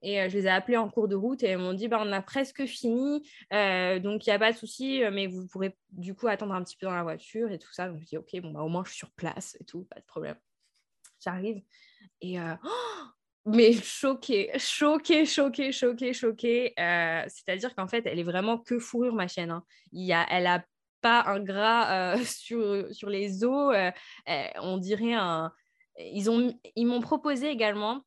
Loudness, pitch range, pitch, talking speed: -28 LUFS, 185-240 Hz, 215 Hz, 225 wpm